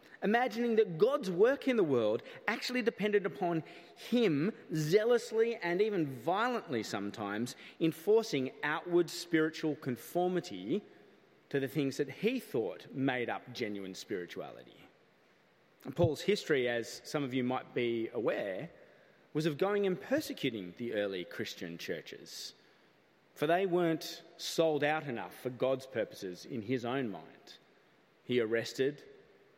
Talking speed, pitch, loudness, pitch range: 130 wpm, 160 Hz, -34 LUFS, 130-205 Hz